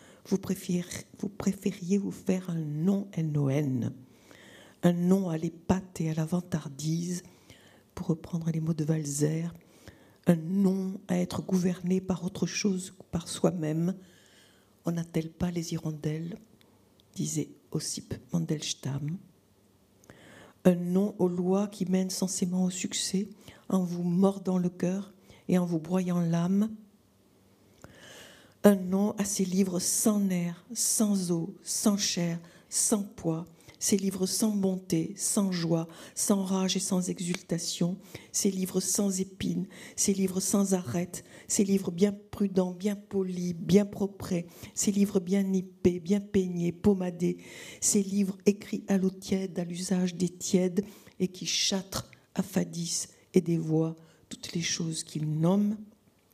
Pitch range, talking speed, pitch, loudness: 170-195 Hz, 135 wpm, 185 Hz, -29 LUFS